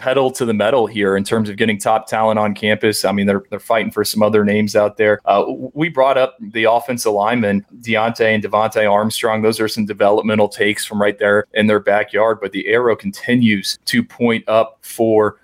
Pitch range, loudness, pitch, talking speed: 105-115 Hz, -16 LUFS, 110 Hz, 210 wpm